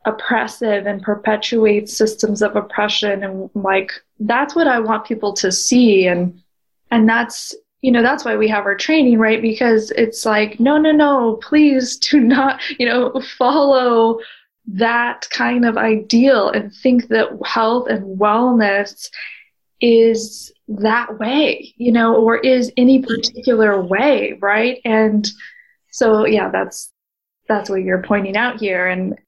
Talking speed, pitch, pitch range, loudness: 145 wpm, 225 Hz, 210-250 Hz, -15 LUFS